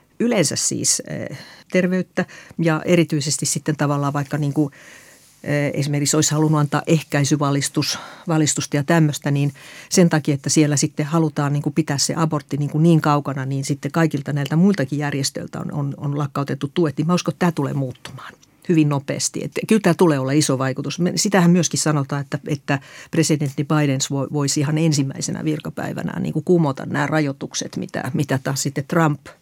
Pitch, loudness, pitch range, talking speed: 150 Hz, -20 LUFS, 145-165 Hz, 165 wpm